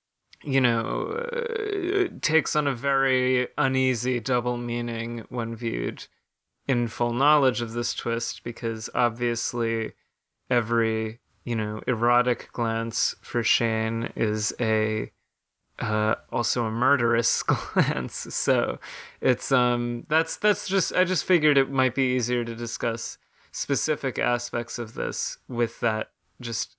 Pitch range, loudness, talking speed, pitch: 115-135 Hz, -25 LUFS, 125 wpm, 120 Hz